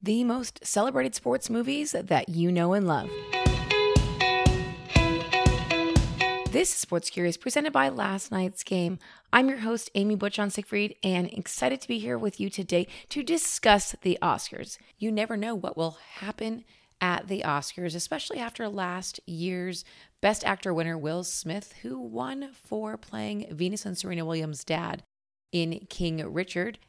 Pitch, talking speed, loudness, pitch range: 180 Hz, 150 wpm, -28 LUFS, 165-210 Hz